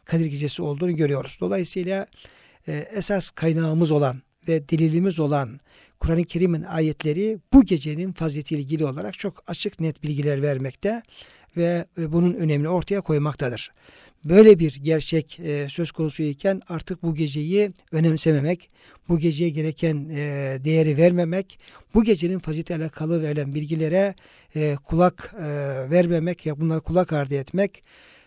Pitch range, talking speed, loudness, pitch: 150-180 Hz, 120 wpm, -23 LUFS, 160 Hz